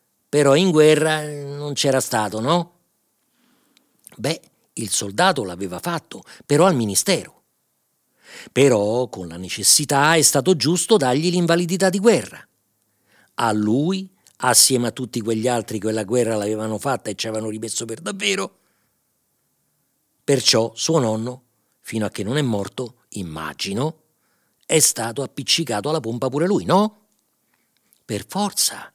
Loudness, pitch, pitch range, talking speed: -19 LUFS, 130 Hz, 110-160 Hz, 135 wpm